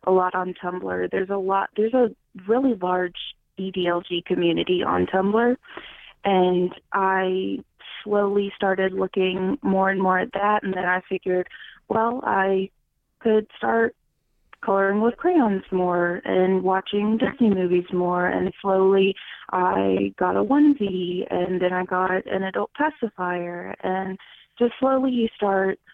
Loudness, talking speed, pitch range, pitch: -23 LUFS, 140 wpm, 180-205 Hz, 190 Hz